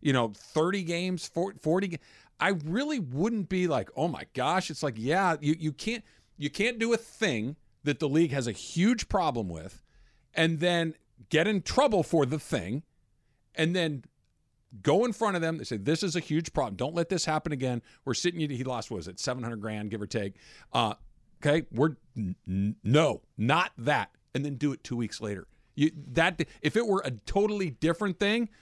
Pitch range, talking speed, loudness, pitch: 125-185 Hz, 205 wpm, -29 LUFS, 155 Hz